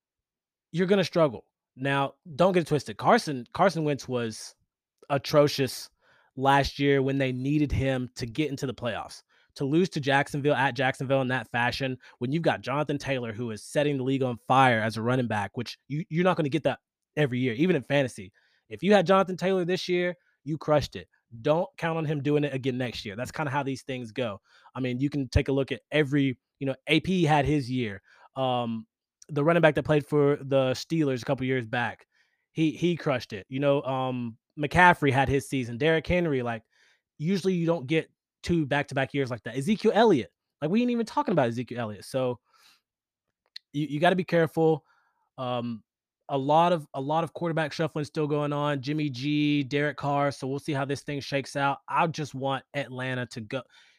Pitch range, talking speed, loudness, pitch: 130-155 Hz, 210 wpm, -27 LUFS, 140 Hz